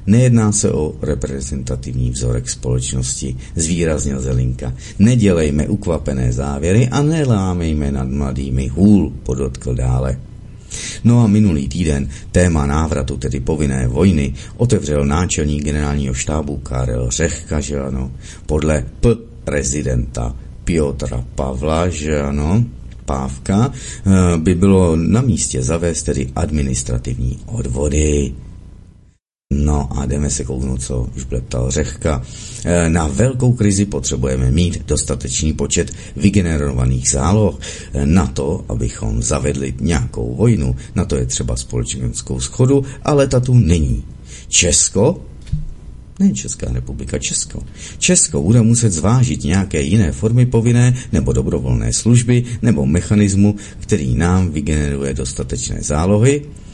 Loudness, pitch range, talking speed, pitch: -17 LUFS, 65-100 Hz, 115 wpm, 75 Hz